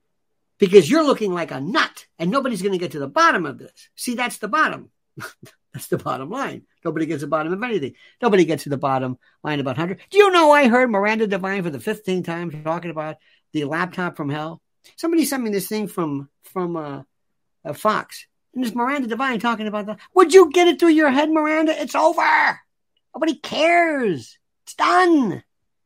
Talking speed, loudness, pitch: 200 wpm, -19 LUFS, 215 Hz